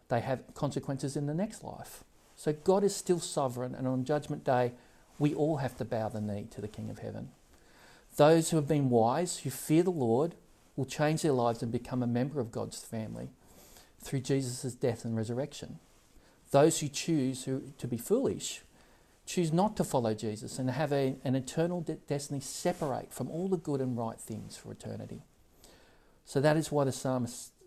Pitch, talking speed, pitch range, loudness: 135 Hz, 190 wpm, 120-150 Hz, -32 LUFS